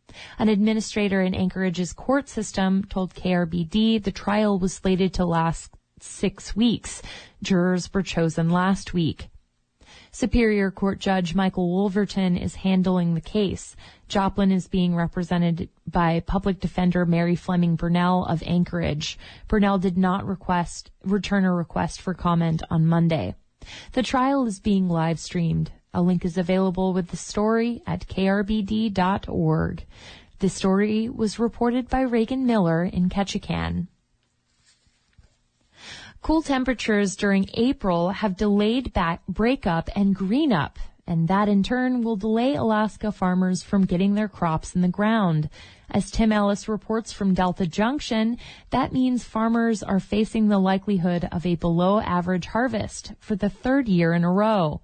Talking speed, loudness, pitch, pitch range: 140 wpm, -23 LUFS, 190 Hz, 175-215 Hz